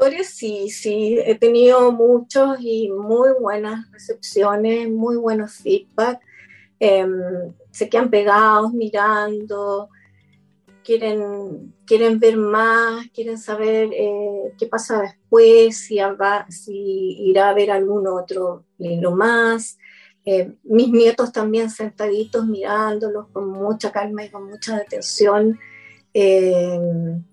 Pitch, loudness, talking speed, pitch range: 215 Hz, -18 LUFS, 110 wpm, 200-230 Hz